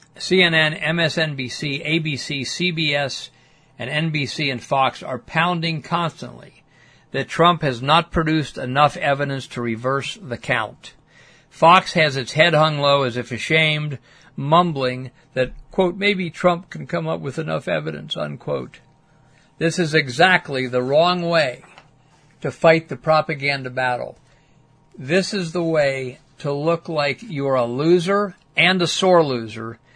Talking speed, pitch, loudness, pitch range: 135 wpm, 155 Hz, -19 LUFS, 135-165 Hz